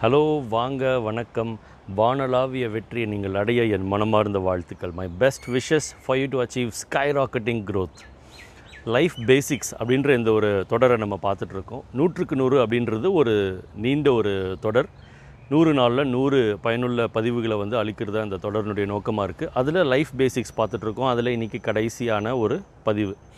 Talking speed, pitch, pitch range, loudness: 145 wpm, 115 Hz, 105-130 Hz, -23 LUFS